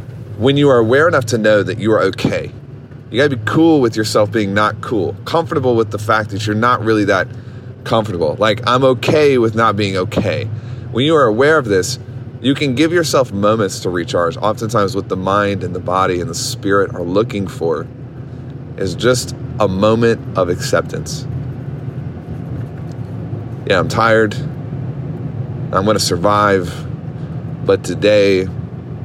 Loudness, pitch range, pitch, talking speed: -15 LUFS, 105-135 Hz, 120 Hz, 160 wpm